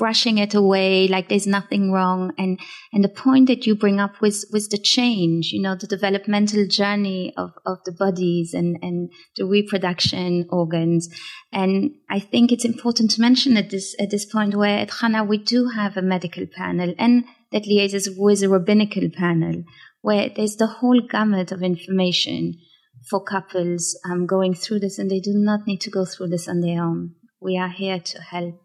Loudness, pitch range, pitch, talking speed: -20 LUFS, 180-210 Hz, 195 Hz, 190 wpm